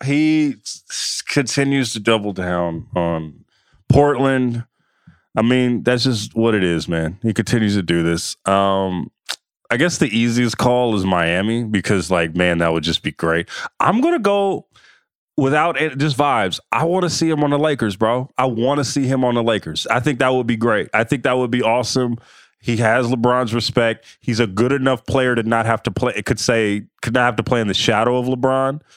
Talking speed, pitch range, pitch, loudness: 205 wpm, 105-135 Hz, 120 Hz, -18 LUFS